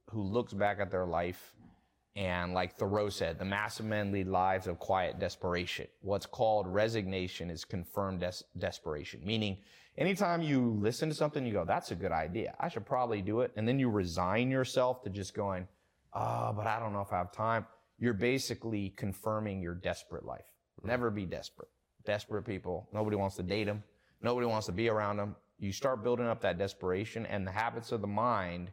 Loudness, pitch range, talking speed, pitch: -35 LUFS, 95-115 Hz, 195 wpm, 105 Hz